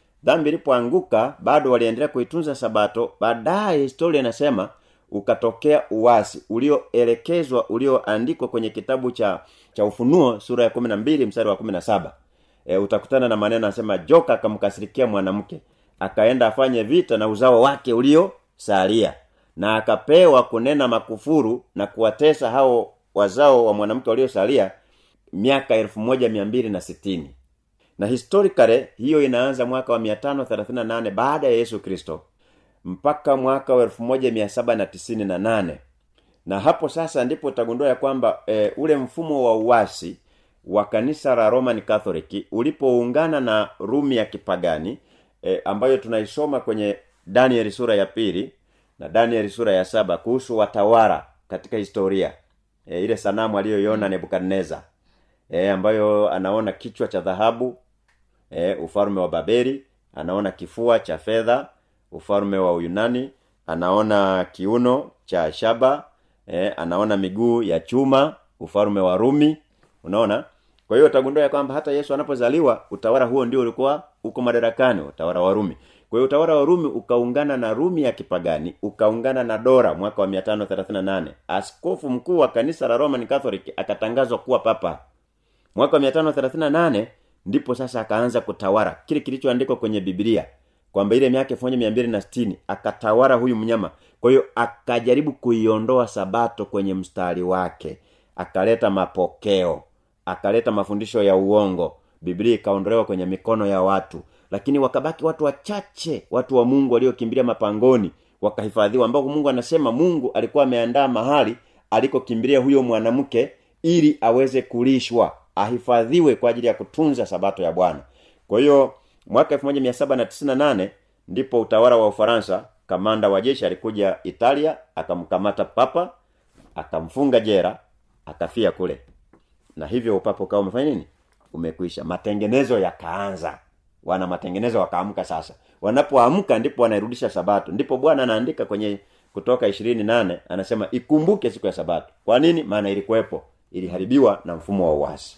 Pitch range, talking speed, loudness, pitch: 100-130 Hz, 110 wpm, -20 LUFS, 115 Hz